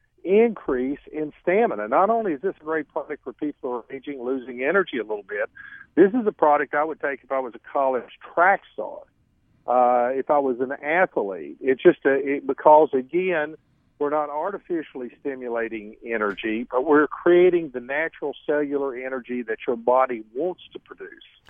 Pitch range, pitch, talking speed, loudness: 125-175 Hz, 145 Hz, 180 wpm, -23 LUFS